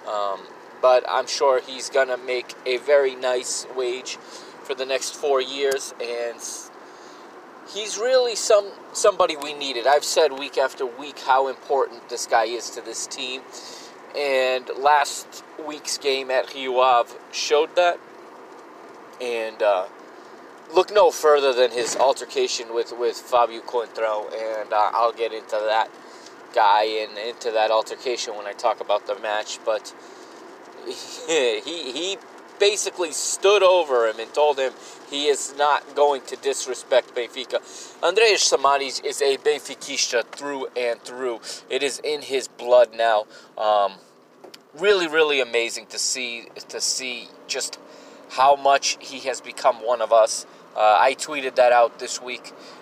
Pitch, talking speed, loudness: 145 Hz, 145 wpm, -22 LUFS